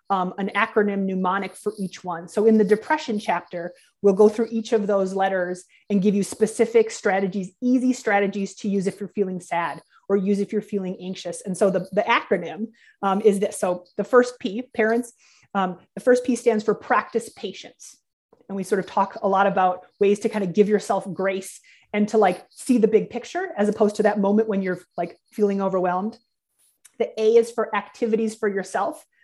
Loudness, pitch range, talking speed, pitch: -23 LUFS, 190-225 Hz, 200 wpm, 205 Hz